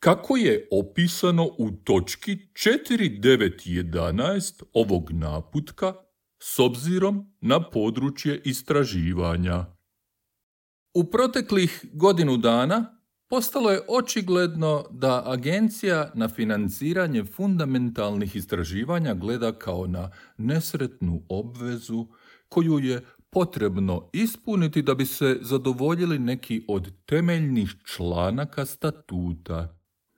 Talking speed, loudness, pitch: 85 wpm, -25 LUFS, 135 Hz